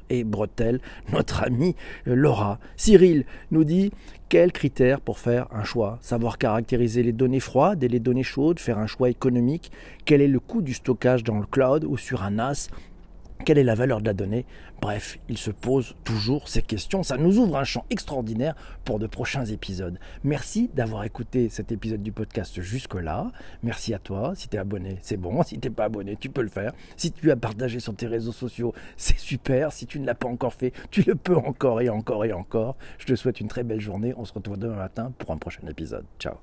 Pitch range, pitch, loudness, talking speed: 110-135 Hz, 120 Hz, -25 LUFS, 215 wpm